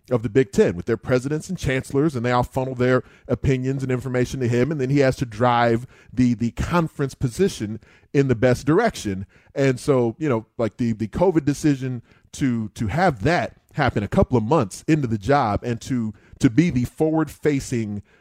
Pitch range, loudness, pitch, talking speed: 115-140 Hz, -22 LUFS, 125 Hz, 200 wpm